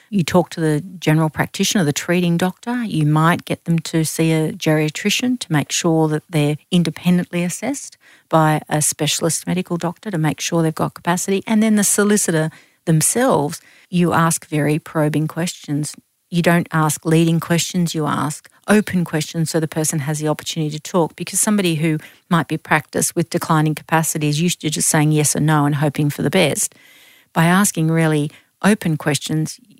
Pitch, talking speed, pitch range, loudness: 165 Hz, 180 wpm, 155-180 Hz, -18 LUFS